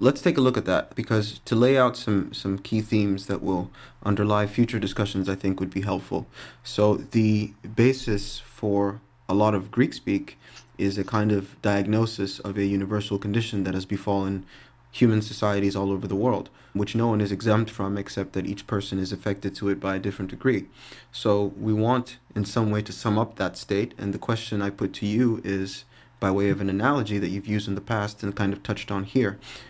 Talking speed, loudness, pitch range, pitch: 210 wpm, -26 LUFS, 100-115 Hz, 105 Hz